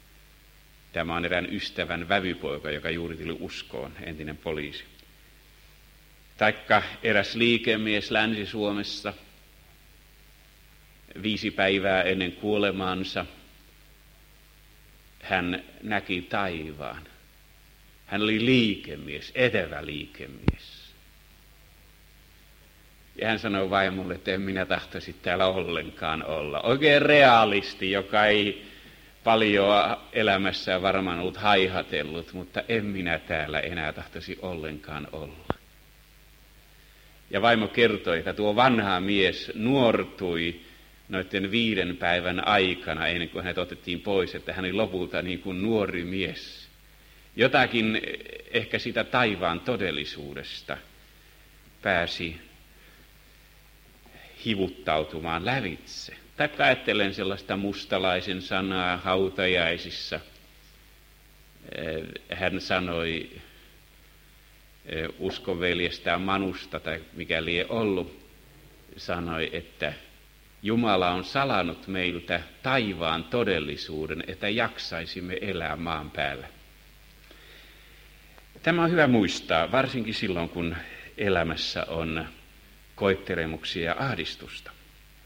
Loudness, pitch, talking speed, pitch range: -26 LUFS, 90 Hz, 90 wpm, 80-100 Hz